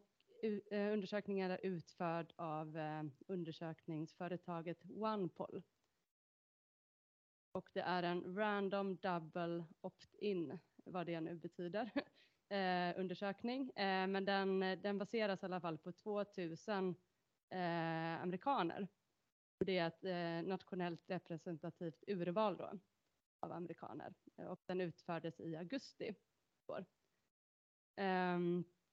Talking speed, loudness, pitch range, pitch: 105 wpm, -44 LUFS, 170-195 Hz, 180 Hz